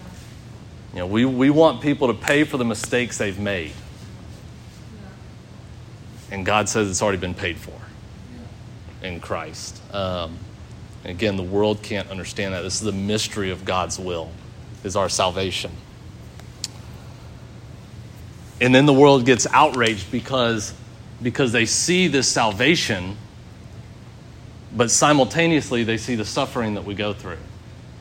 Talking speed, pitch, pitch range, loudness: 135 wpm, 110 Hz, 100-120 Hz, -20 LUFS